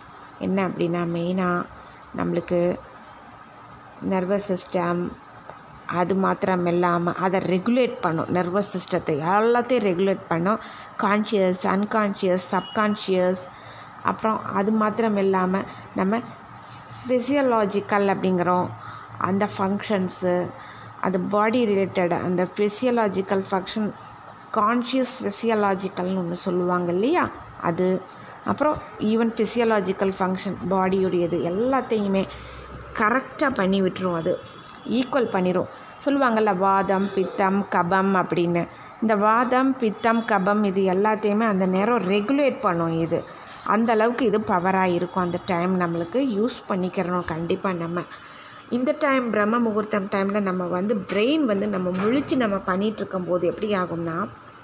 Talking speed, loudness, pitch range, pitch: 110 wpm, -23 LUFS, 180-215 Hz, 195 Hz